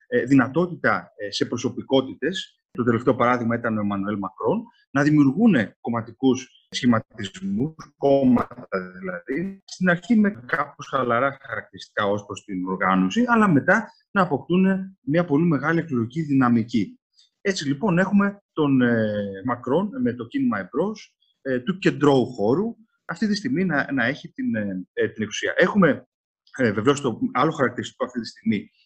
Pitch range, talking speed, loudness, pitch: 120-195 Hz, 135 wpm, -23 LUFS, 140 Hz